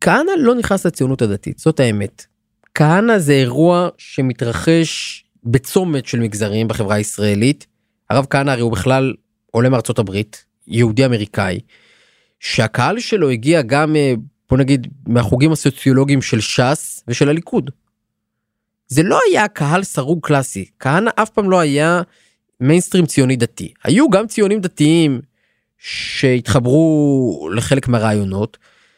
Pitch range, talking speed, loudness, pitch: 115-160 Hz, 120 wpm, -16 LUFS, 135 Hz